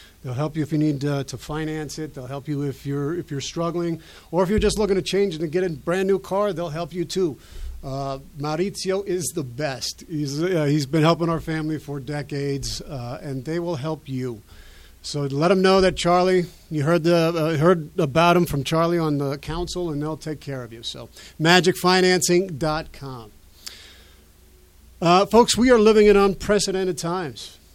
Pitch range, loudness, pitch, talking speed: 140-180 Hz, -22 LUFS, 155 Hz, 190 wpm